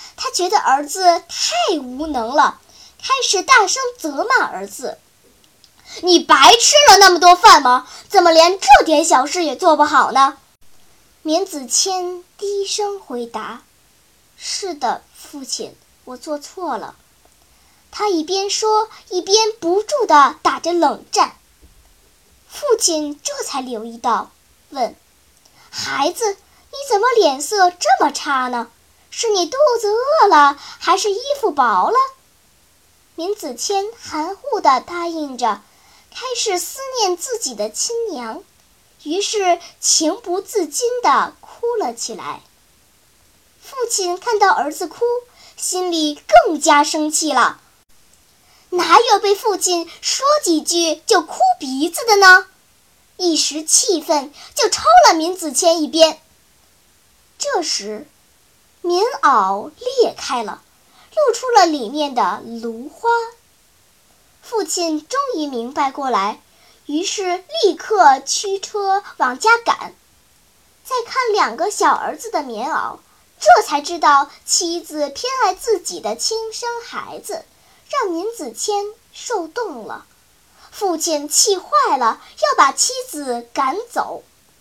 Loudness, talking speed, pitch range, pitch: -16 LUFS, 170 characters per minute, 300-415 Hz, 355 Hz